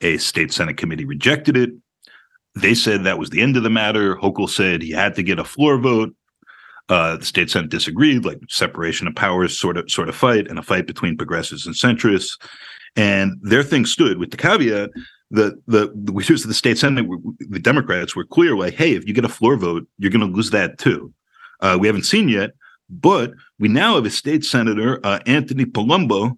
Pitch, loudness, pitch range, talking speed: 110 Hz, -18 LUFS, 100-125 Hz, 215 wpm